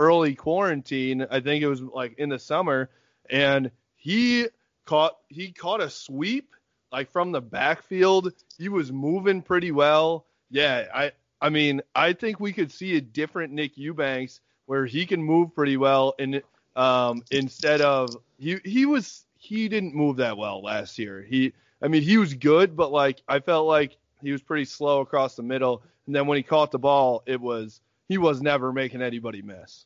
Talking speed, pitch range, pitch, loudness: 185 wpm, 130-165 Hz, 145 Hz, -24 LUFS